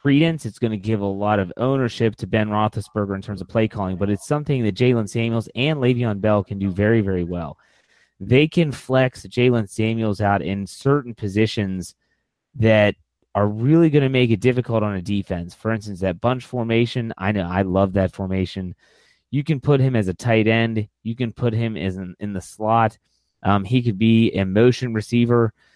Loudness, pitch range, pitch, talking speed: -21 LUFS, 100-120 Hz, 110 Hz, 200 wpm